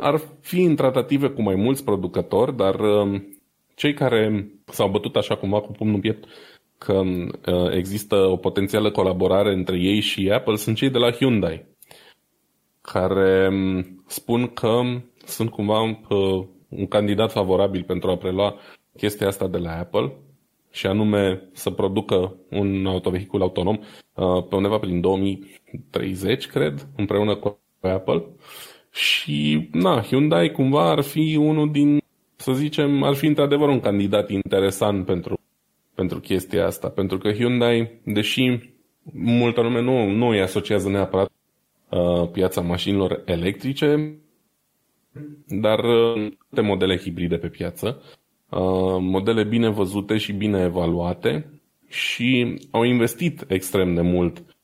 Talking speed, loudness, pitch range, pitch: 130 wpm, -22 LUFS, 95-120 Hz, 100 Hz